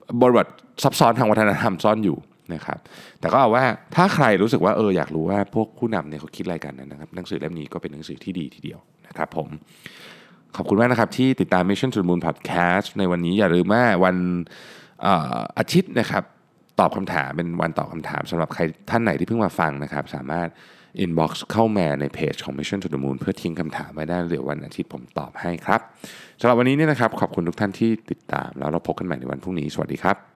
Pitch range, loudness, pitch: 80-105 Hz, -22 LUFS, 90 Hz